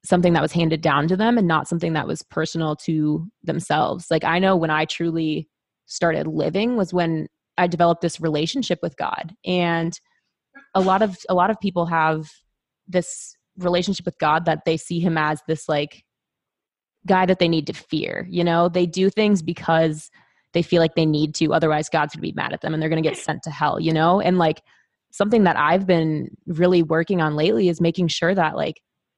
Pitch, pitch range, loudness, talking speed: 170 Hz, 160-180 Hz, -21 LUFS, 210 wpm